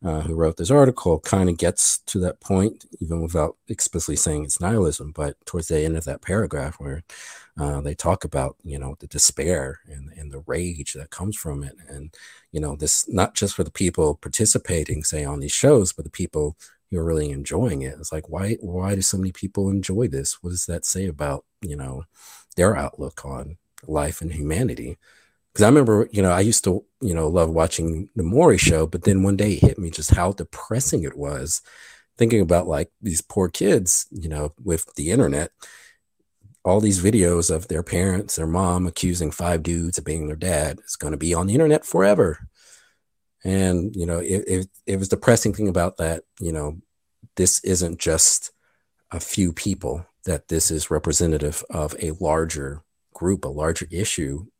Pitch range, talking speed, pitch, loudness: 75-95 Hz, 195 wpm, 85 Hz, -22 LUFS